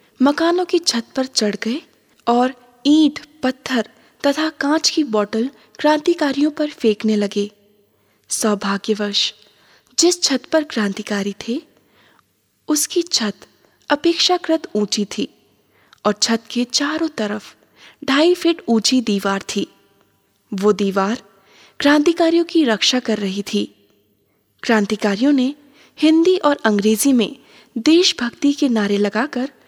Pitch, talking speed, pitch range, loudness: 245 Hz, 115 wpm, 210-300 Hz, -18 LUFS